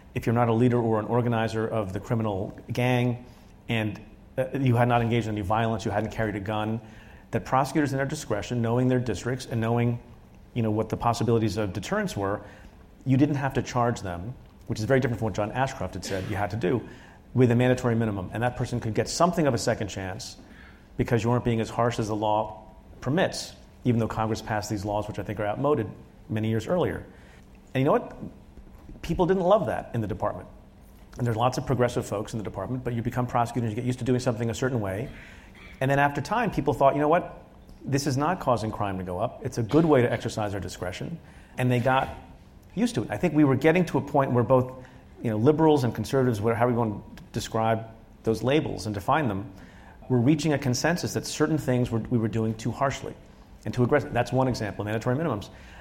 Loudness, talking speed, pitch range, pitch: -26 LUFS, 230 wpm, 110-130 Hz, 120 Hz